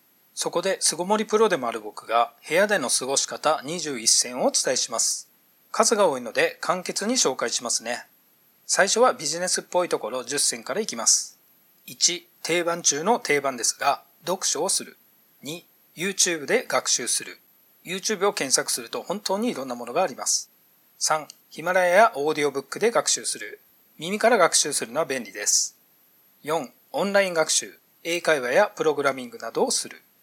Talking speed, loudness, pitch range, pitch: 340 characters per minute, -23 LUFS, 145-200 Hz, 170 Hz